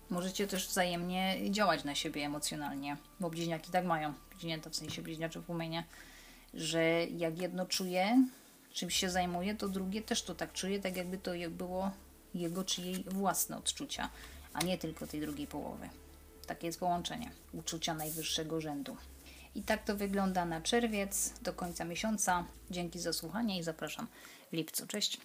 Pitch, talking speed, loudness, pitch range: 180 Hz, 160 wpm, -36 LUFS, 165-195 Hz